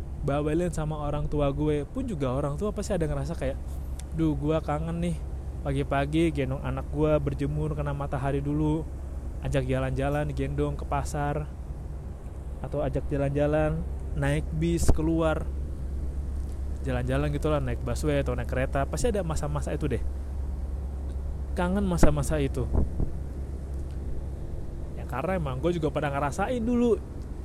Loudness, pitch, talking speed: -29 LUFS, 75 Hz, 130 wpm